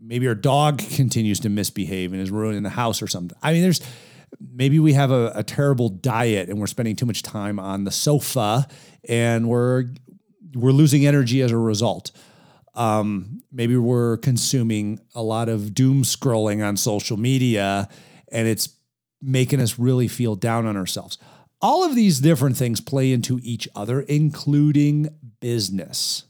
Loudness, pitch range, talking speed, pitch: -21 LUFS, 110-140 Hz, 165 wpm, 120 Hz